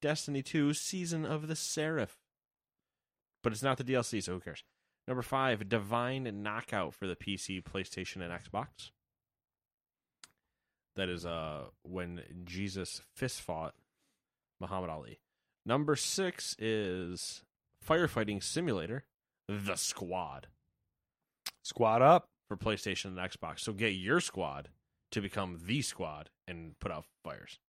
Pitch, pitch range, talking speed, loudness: 100 Hz, 90-130 Hz, 125 wpm, -35 LUFS